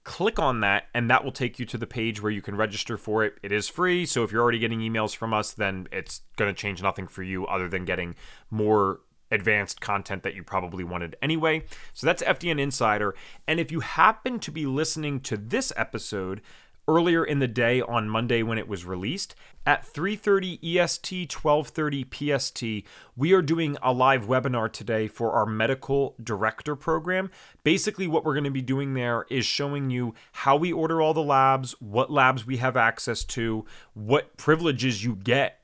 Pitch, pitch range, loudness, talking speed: 125 Hz, 110-150 Hz, -26 LUFS, 195 wpm